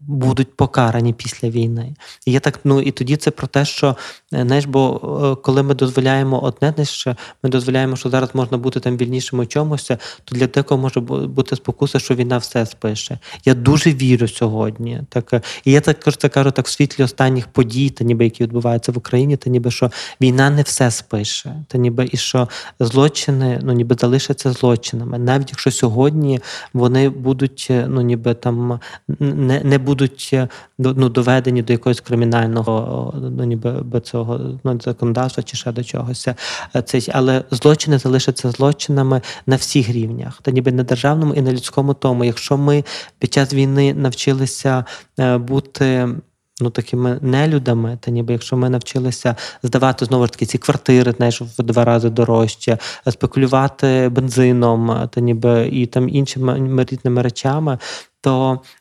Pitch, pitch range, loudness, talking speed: 130 Hz, 120-135 Hz, -17 LUFS, 165 wpm